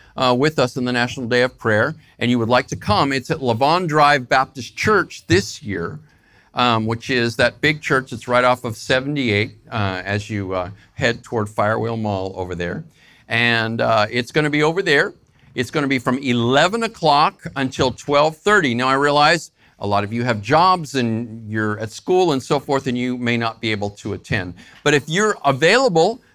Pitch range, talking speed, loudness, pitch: 110-145 Hz, 205 wpm, -18 LUFS, 125 Hz